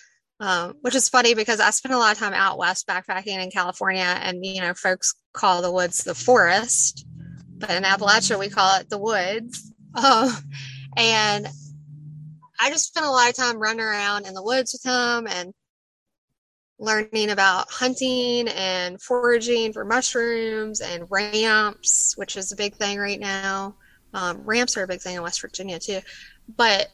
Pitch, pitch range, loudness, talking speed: 205 Hz, 185-230 Hz, -21 LUFS, 170 wpm